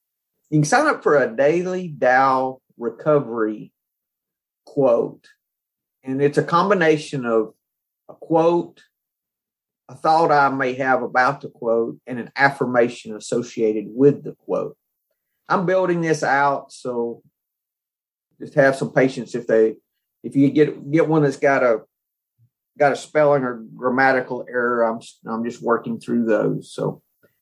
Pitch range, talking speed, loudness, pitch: 120-150 Hz, 140 wpm, -20 LUFS, 135 Hz